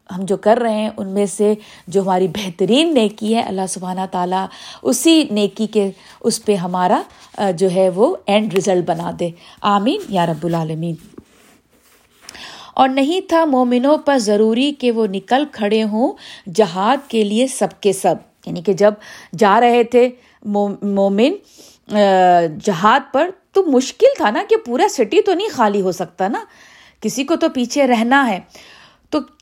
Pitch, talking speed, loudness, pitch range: 215 Hz, 160 wpm, -16 LUFS, 195-265 Hz